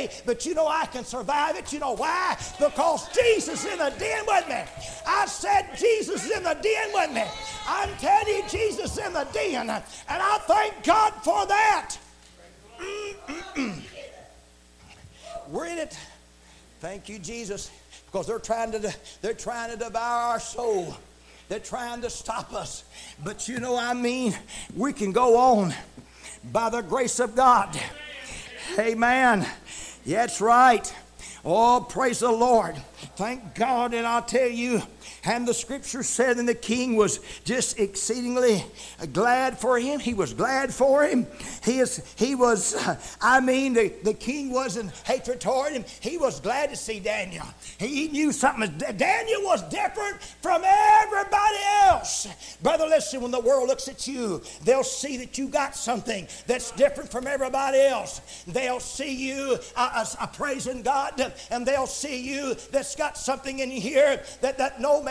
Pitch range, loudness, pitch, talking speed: 235-295 Hz, -25 LUFS, 255 Hz, 165 wpm